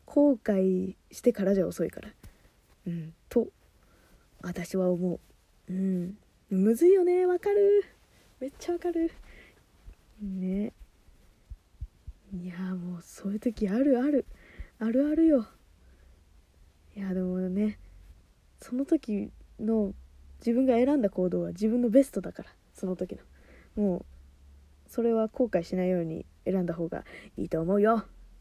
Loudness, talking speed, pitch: -28 LUFS, 230 characters per minute, 190 Hz